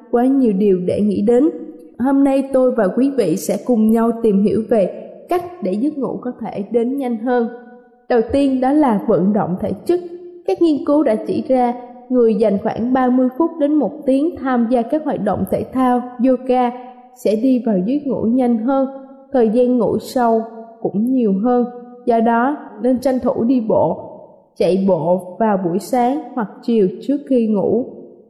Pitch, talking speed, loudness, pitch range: 245 Hz, 185 wpm, -17 LUFS, 220-265 Hz